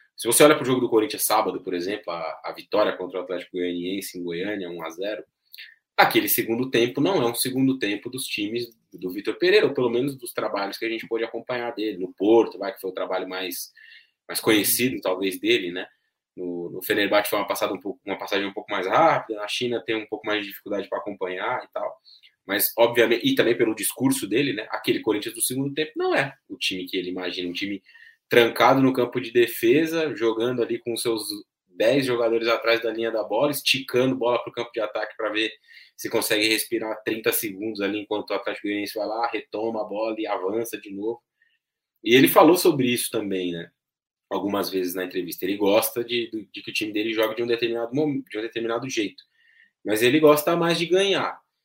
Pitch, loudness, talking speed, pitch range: 115 Hz, -23 LUFS, 215 wpm, 105-165 Hz